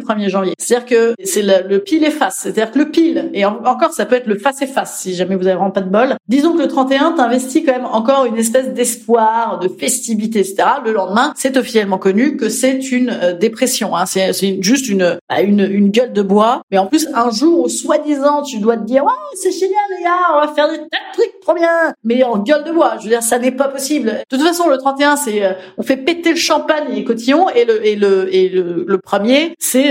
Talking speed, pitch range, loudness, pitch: 250 wpm, 205-295 Hz, -14 LUFS, 250 Hz